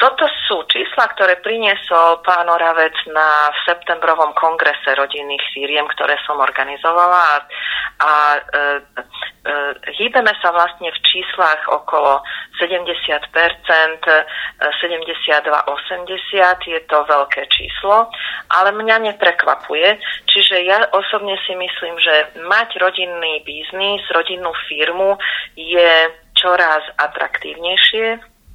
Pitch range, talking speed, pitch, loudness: 155-185 Hz, 100 wpm, 170 Hz, -15 LUFS